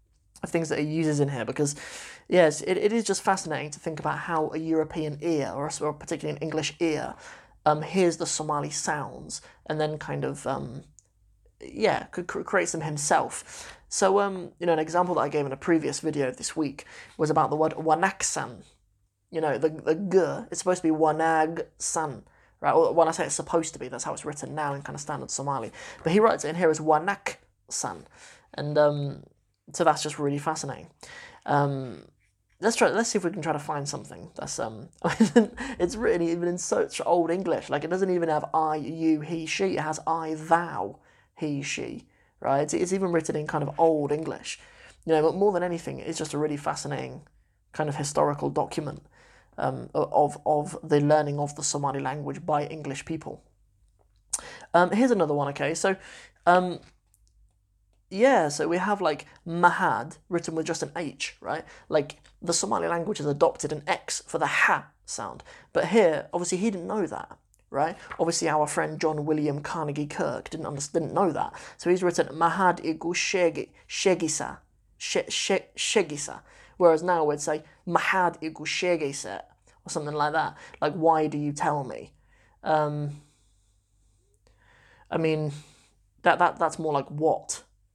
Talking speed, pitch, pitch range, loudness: 185 wpm, 155 Hz, 145-170 Hz, -27 LUFS